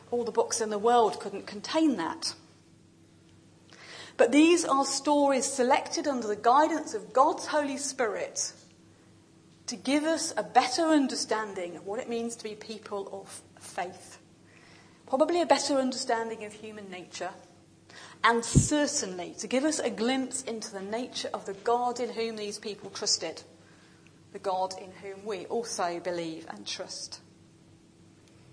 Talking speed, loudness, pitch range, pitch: 145 wpm, -29 LUFS, 210-280 Hz, 235 Hz